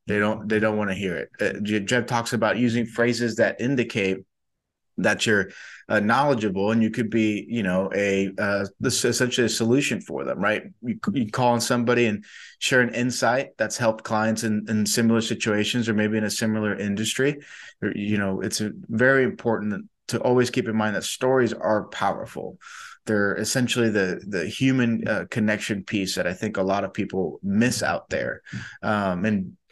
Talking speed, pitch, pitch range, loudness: 185 wpm, 110 Hz, 105-120 Hz, -24 LUFS